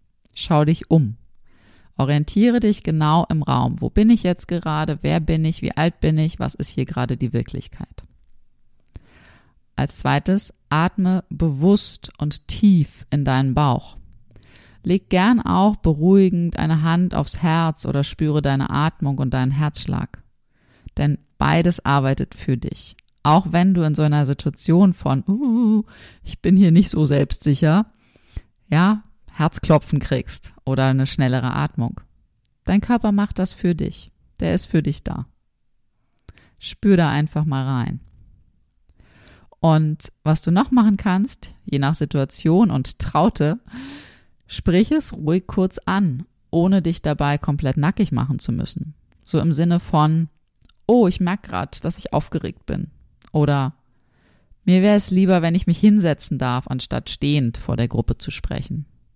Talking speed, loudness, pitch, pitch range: 150 wpm, -19 LUFS, 155 Hz, 135-185 Hz